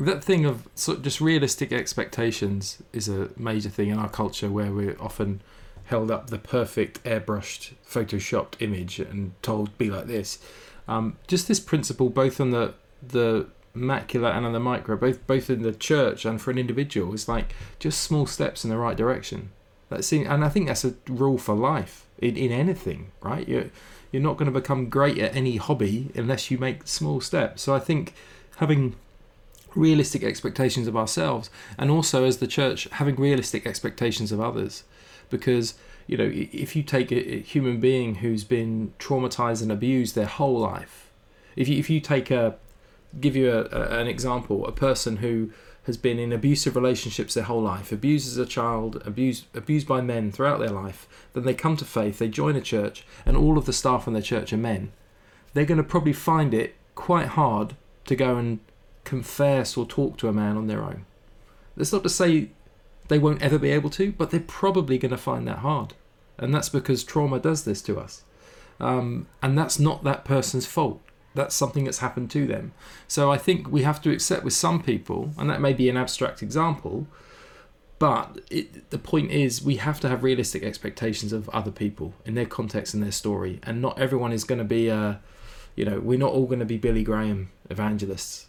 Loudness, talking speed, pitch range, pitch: -25 LUFS, 200 wpm, 110-140 Hz, 125 Hz